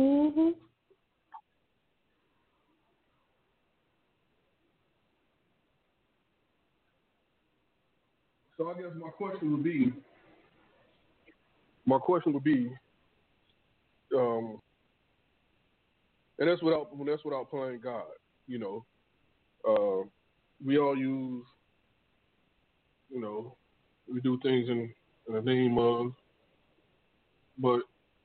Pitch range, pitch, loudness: 120-175 Hz, 135 Hz, -31 LUFS